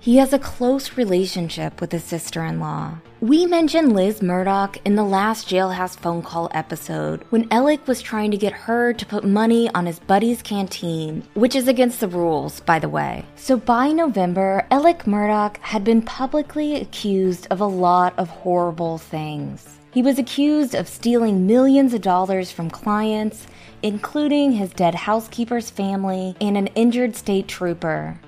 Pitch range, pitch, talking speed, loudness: 180-240 Hz, 205 Hz, 165 wpm, -20 LUFS